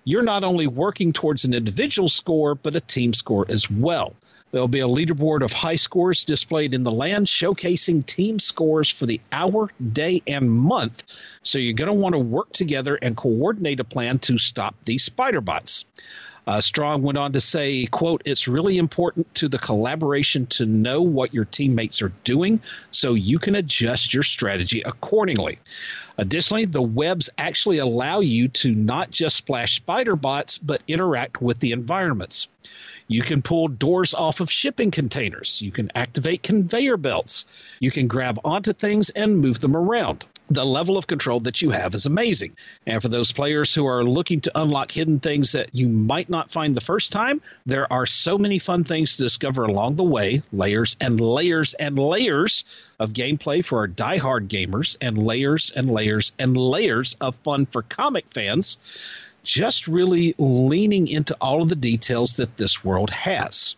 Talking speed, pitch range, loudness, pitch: 180 wpm, 120-165 Hz, -21 LUFS, 140 Hz